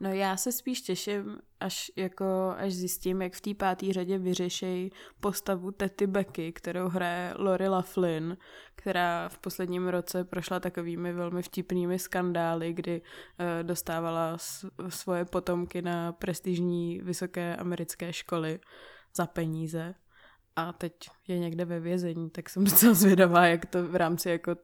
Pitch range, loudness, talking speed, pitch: 175-190 Hz, -30 LUFS, 140 wpm, 180 Hz